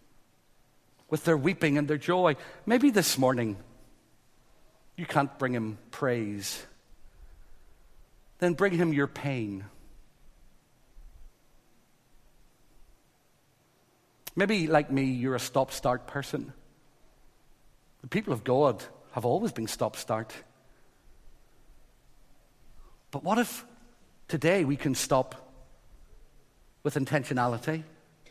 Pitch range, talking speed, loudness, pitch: 125-165 Hz, 95 wpm, -29 LUFS, 140 Hz